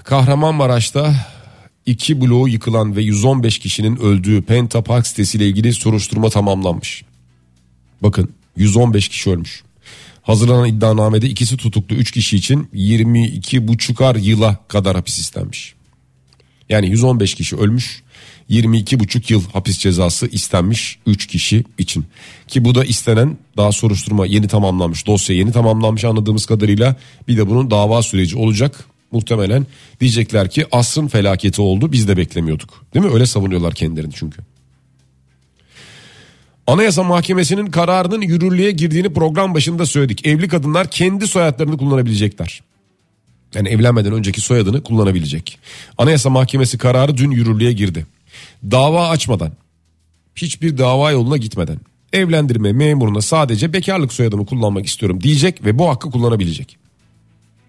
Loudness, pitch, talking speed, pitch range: -15 LUFS, 115 Hz, 125 wpm, 100-130 Hz